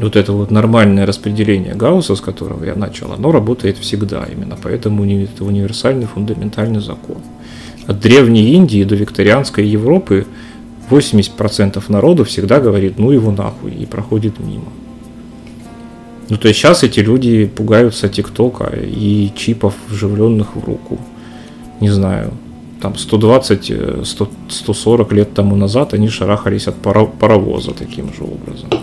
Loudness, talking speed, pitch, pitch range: -13 LUFS, 135 wpm, 105 Hz, 100-115 Hz